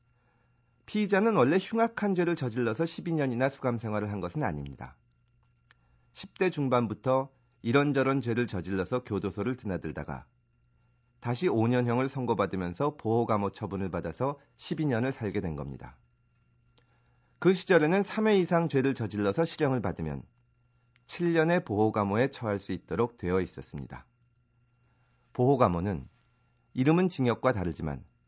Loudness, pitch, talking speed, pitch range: -29 LUFS, 125 Hz, 295 characters per minute, 100-135 Hz